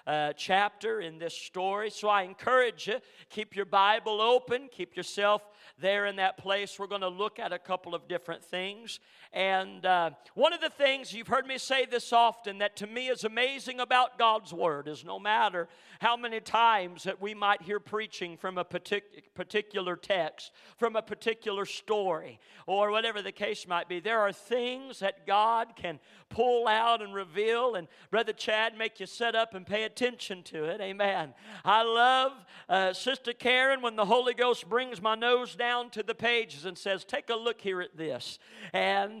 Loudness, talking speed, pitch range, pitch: -30 LUFS, 185 wpm, 190-235 Hz, 210 Hz